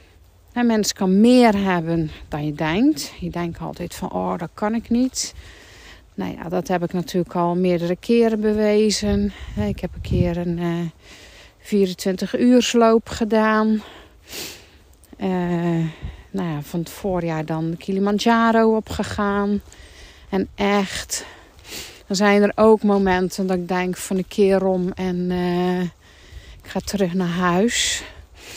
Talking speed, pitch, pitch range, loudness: 140 wpm, 185 Hz, 170-210 Hz, -20 LUFS